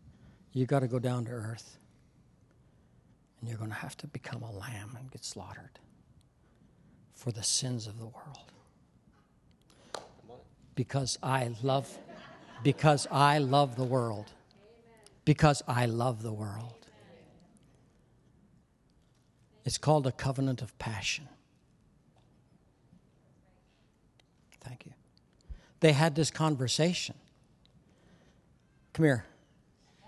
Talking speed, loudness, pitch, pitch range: 105 wpm, -31 LUFS, 130 Hz, 115-145 Hz